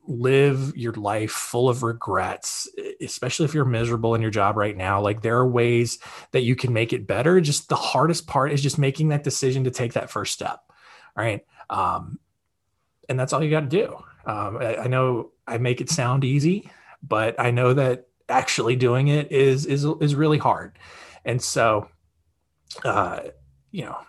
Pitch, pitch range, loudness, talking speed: 125 Hz, 115-145 Hz, -23 LUFS, 185 wpm